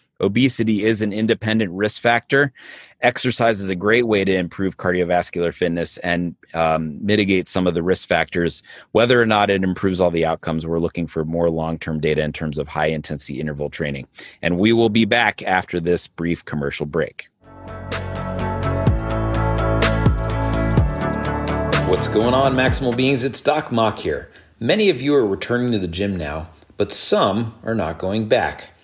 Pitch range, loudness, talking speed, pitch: 85-110 Hz, -20 LUFS, 165 wpm, 95 Hz